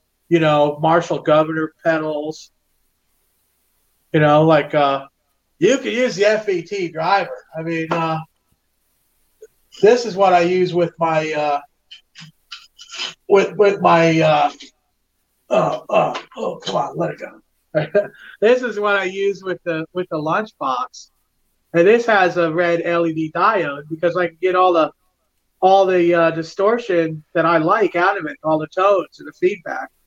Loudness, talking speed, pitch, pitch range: -18 LUFS, 155 wpm, 170 Hz, 155-195 Hz